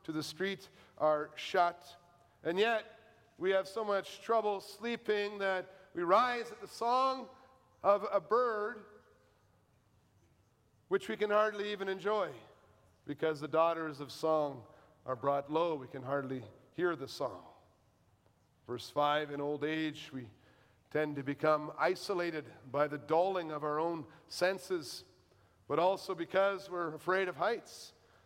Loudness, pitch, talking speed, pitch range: -35 LUFS, 165 Hz, 140 wpm, 145-195 Hz